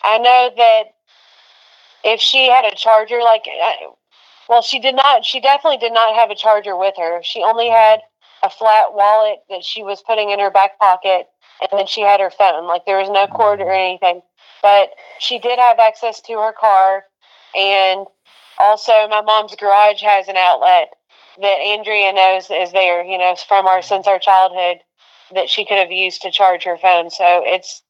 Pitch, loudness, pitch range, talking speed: 200 Hz, -14 LUFS, 190-225 Hz, 190 wpm